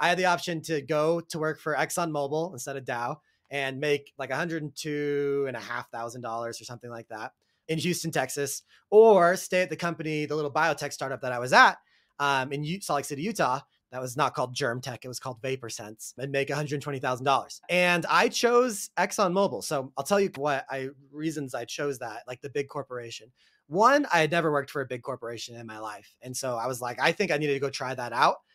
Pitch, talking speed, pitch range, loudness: 145 Hz, 210 wpm, 130-160 Hz, -27 LUFS